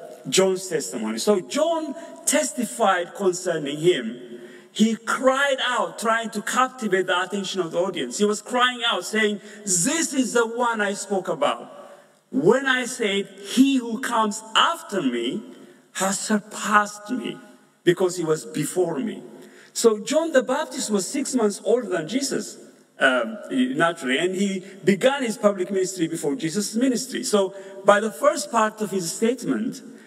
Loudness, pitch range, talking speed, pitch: -23 LUFS, 190-255 Hz, 150 wpm, 210 Hz